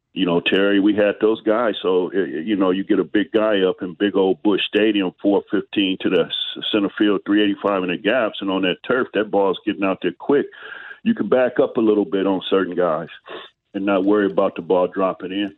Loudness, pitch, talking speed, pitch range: -19 LUFS, 100 Hz, 225 wpm, 95-105 Hz